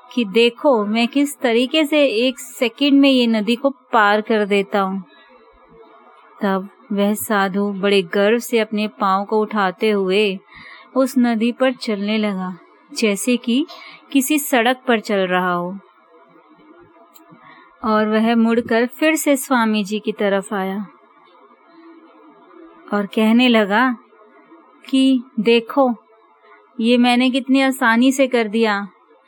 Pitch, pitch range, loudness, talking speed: 230 Hz, 210-260 Hz, -17 LUFS, 125 wpm